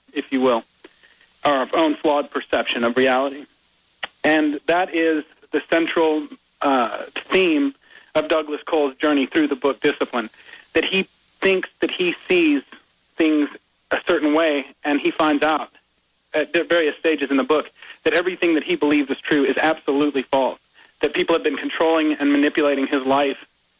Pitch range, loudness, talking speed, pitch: 145-170 Hz, -20 LUFS, 160 wpm, 155 Hz